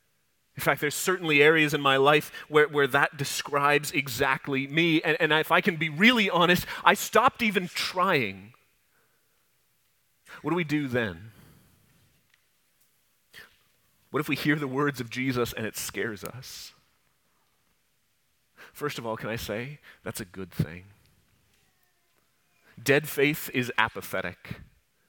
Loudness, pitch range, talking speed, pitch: -25 LUFS, 115-155 Hz, 135 wpm, 140 Hz